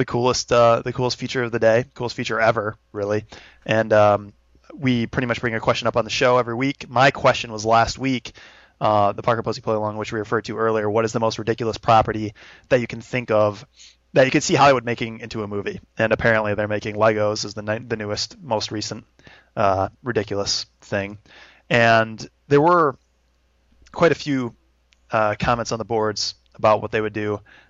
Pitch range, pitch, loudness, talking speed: 105-120 Hz, 110 Hz, -21 LUFS, 205 wpm